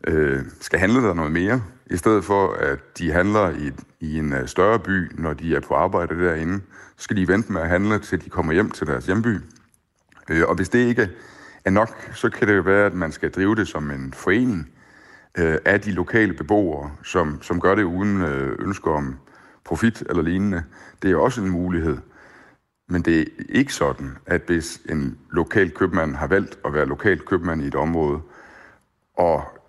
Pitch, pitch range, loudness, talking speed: 90 Hz, 80-100 Hz, -21 LUFS, 190 wpm